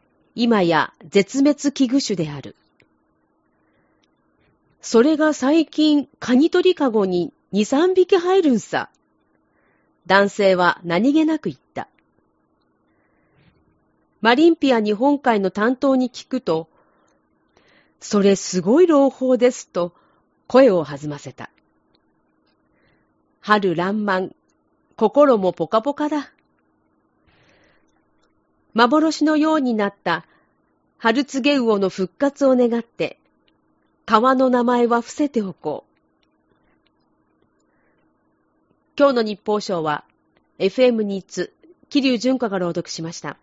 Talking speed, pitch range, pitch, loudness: 190 characters per minute, 185-280 Hz, 235 Hz, -19 LUFS